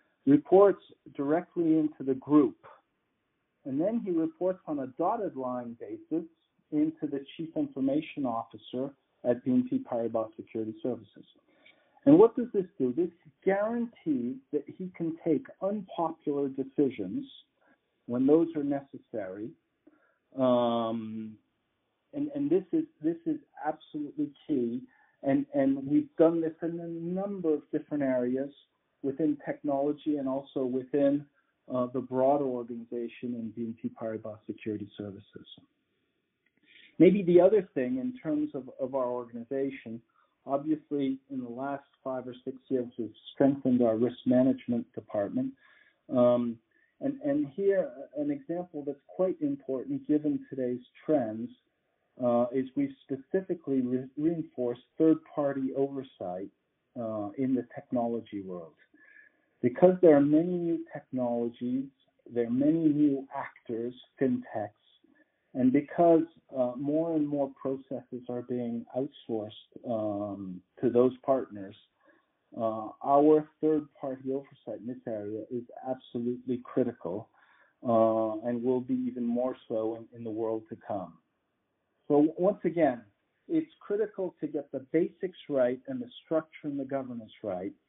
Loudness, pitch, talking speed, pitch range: -30 LUFS, 140 Hz, 130 wpm, 125-180 Hz